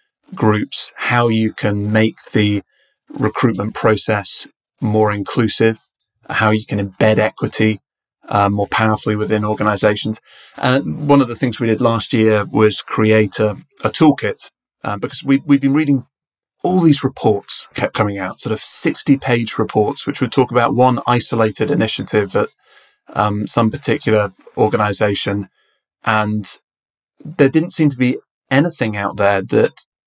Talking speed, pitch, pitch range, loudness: 145 wpm, 110 Hz, 105-130 Hz, -17 LUFS